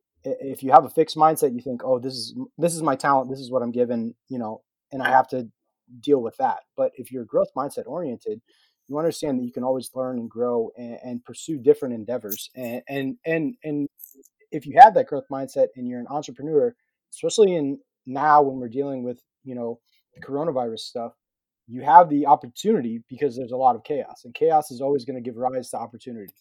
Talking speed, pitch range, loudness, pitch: 215 wpm, 125-155 Hz, -23 LUFS, 135 Hz